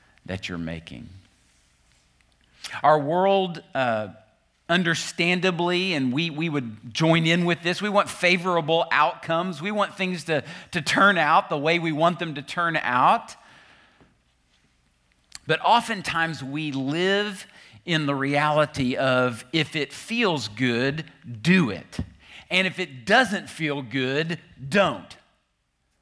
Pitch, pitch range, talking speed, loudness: 150 Hz, 120-175 Hz, 125 wpm, -23 LUFS